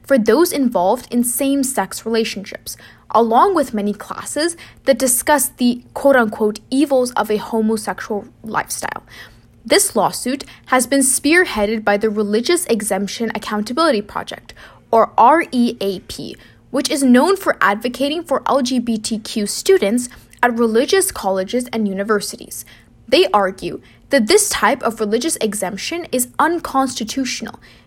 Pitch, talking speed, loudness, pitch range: 235 Hz, 125 wpm, -17 LUFS, 210-275 Hz